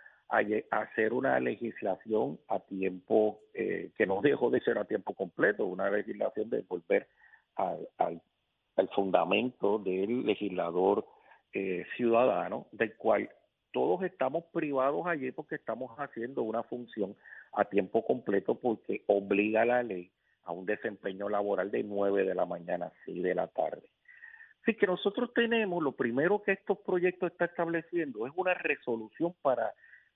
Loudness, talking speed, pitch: -32 LUFS, 145 wpm, 165 Hz